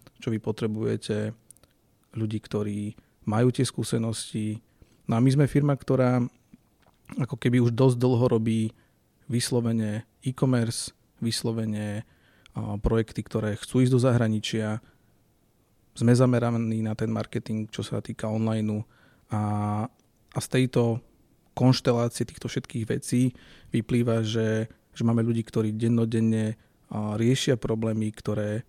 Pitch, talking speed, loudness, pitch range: 115 Hz, 115 wpm, -27 LUFS, 110-125 Hz